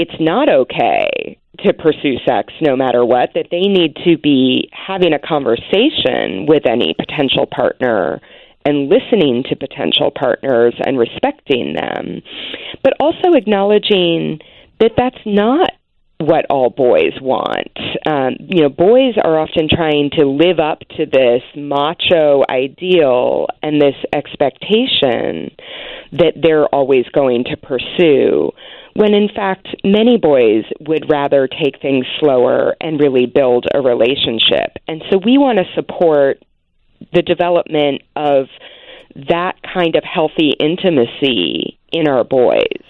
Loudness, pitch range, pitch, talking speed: -14 LUFS, 140-210 Hz, 165 Hz, 130 wpm